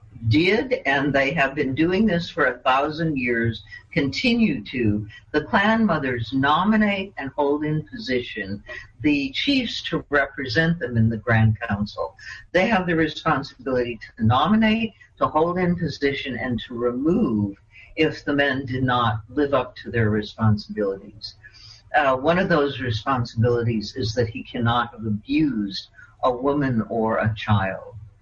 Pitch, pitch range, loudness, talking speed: 130 Hz, 110-150 Hz, -22 LUFS, 145 wpm